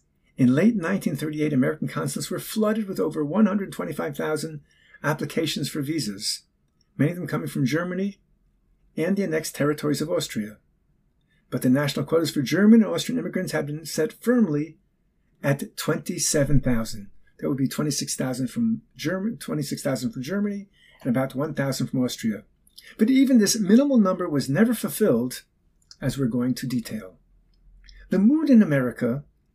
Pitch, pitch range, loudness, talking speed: 155 Hz, 130-210 Hz, -24 LUFS, 145 wpm